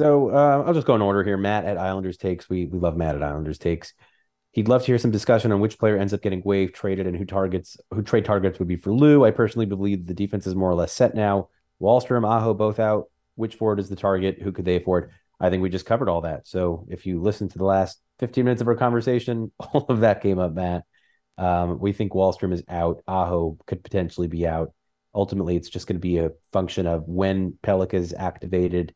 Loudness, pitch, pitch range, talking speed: -23 LUFS, 95 Hz, 90-105 Hz, 240 wpm